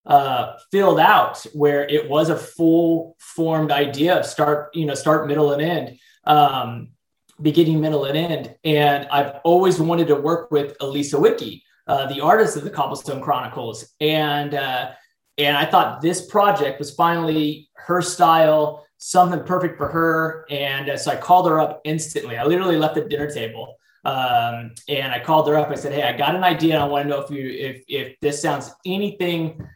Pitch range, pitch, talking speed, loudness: 145-165 Hz, 150 Hz, 185 wpm, -19 LUFS